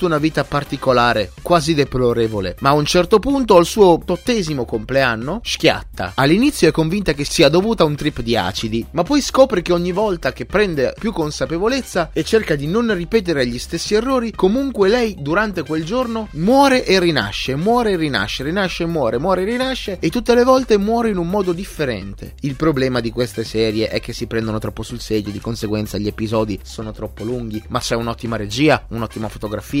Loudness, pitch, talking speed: -17 LUFS, 155 Hz, 195 wpm